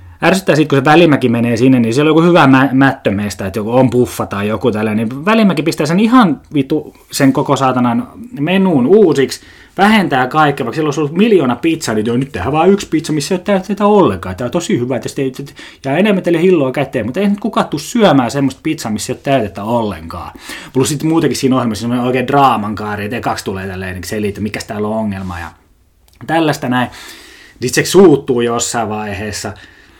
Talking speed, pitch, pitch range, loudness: 205 wpm, 135 Hz, 110-160 Hz, -13 LUFS